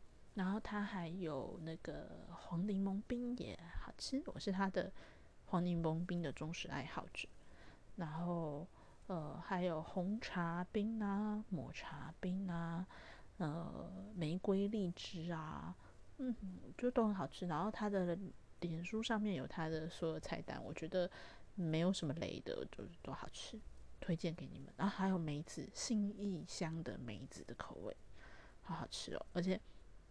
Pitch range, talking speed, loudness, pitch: 165-200 Hz, 215 characters per minute, -43 LUFS, 180 Hz